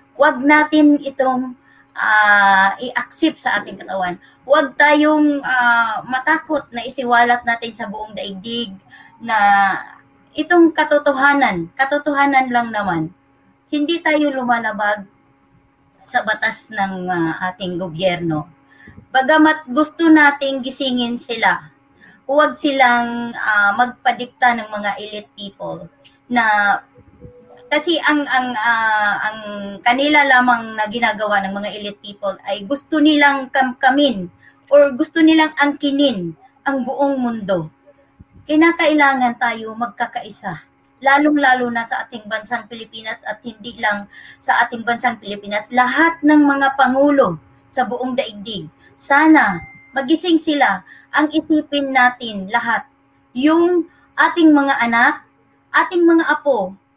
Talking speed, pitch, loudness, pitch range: 115 wpm, 245 Hz, -16 LUFS, 210-285 Hz